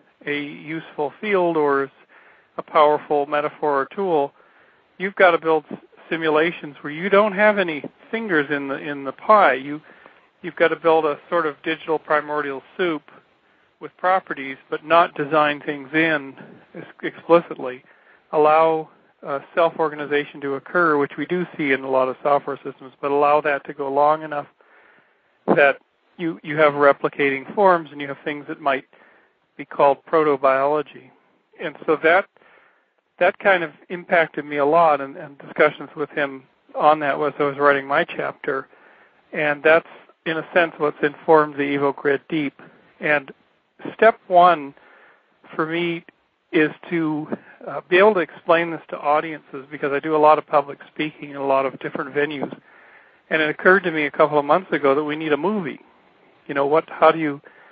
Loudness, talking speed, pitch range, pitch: -20 LUFS, 170 wpm, 145-165 Hz, 155 Hz